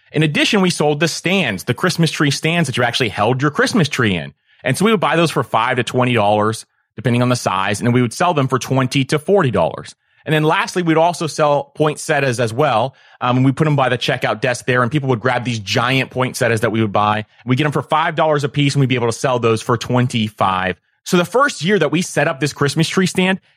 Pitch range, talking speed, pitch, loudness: 125-160 Hz, 265 wpm, 140 Hz, -16 LUFS